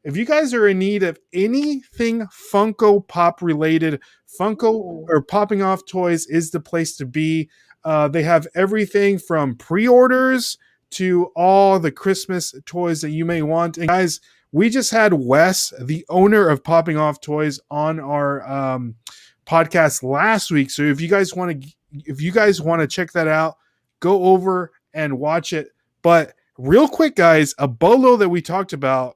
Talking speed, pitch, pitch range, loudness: 170 wpm, 170 Hz, 155-195 Hz, -18 LUFS